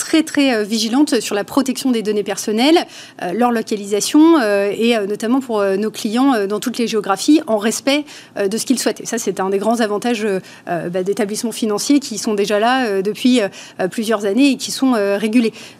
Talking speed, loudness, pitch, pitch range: 215 wpm, -17 LUFS, 225 Hz, 205-255 Hz